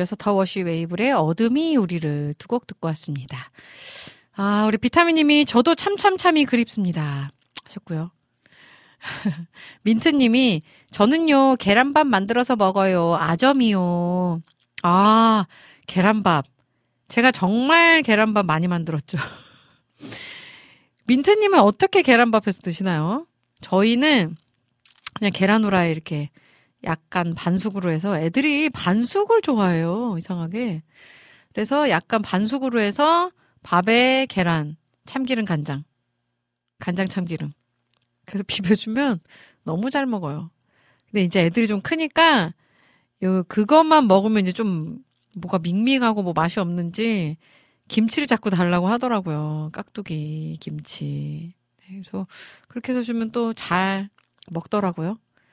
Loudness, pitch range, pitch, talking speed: -20 LUFS, 165-240 Hz, 195 Hz, 260 characters per minute